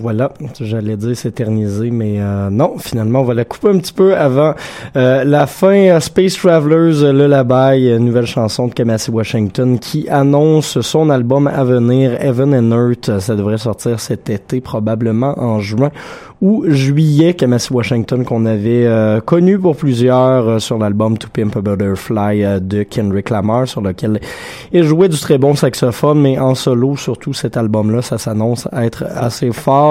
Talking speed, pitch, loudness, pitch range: 170 wpm, 125 Hz, -13 LUFS, 110-145 Hz